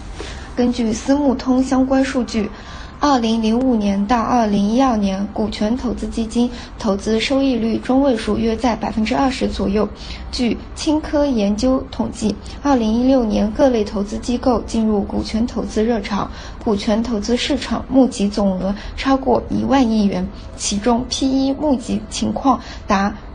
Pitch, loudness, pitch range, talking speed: 235 Hz, -18 LUFS, 215-260 Hz, 240 characters per minute